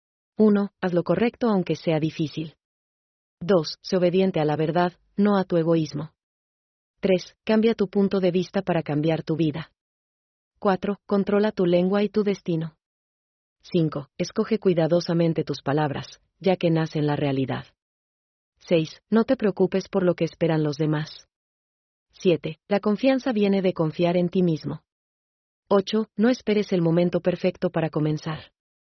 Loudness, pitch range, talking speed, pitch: -24 LUFS, 160-200 Hz, 145 wpm, 175 Hz